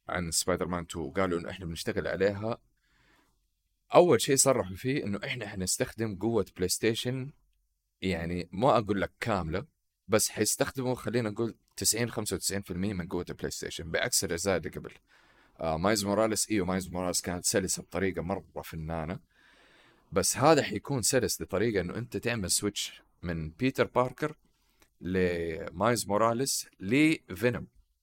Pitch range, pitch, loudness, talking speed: 90-120 Hz, 100 Hz, -30 LUFS, 135 wpm